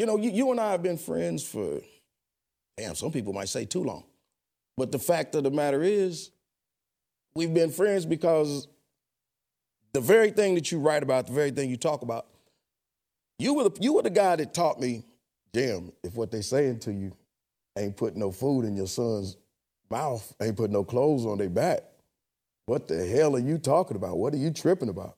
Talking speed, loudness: 205 wpm, -27 LUFS